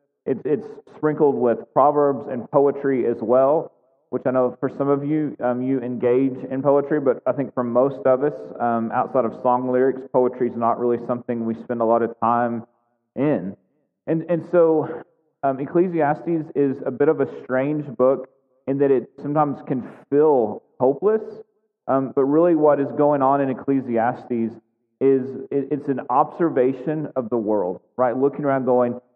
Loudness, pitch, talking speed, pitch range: -21 LUFS, 135 Hz, 175 wpm, 125-150 Hz